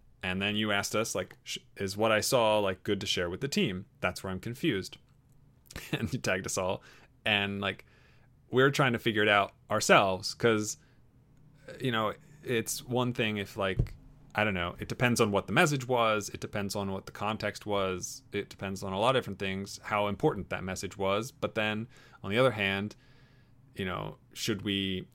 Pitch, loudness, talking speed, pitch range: 105 Hz, -30 LUFS, 200 wpm, 100-125 Hz